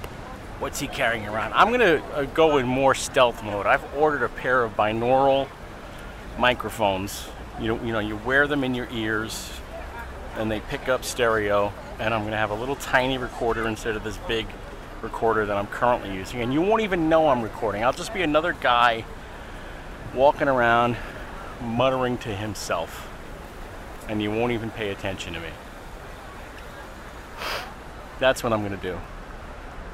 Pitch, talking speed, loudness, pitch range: 110 Hz, 165 wpm, -24 LUFS, 100-125 Hz